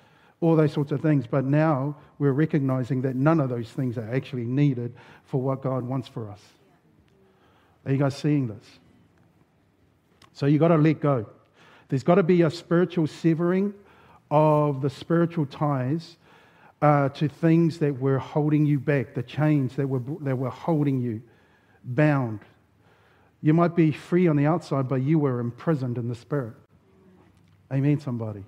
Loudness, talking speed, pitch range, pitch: -24 LUFS, 165 wpm, 130-155 Hz, 145 Hz